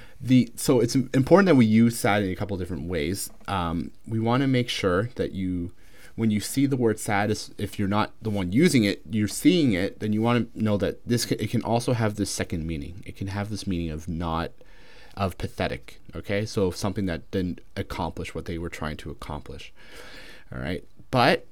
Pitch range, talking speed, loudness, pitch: 90-115 Hz, 215 wpm, -25 LUFS, 100 Hz